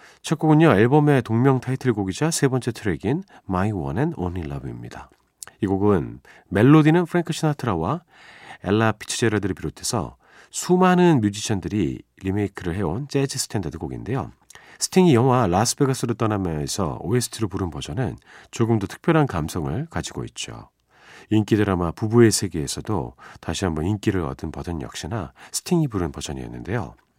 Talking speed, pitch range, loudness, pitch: 375 characters per minute, 90-135 Hz, -22 LUFS, 110 Hz